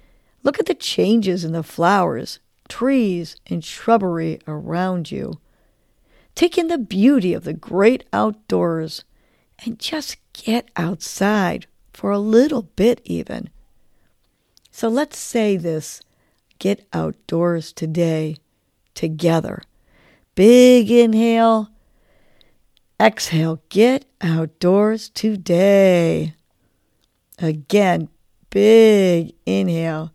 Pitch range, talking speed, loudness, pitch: 165-230 Hz, 90 wpm, -18 LUFS, 185 Hz